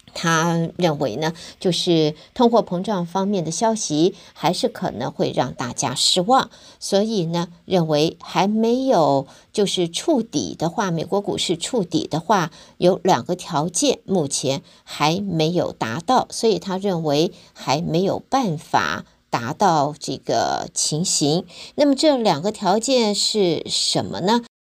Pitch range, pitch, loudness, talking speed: 160-210 Hz, 180 Hz, -20 LUFS, 210 characters per minute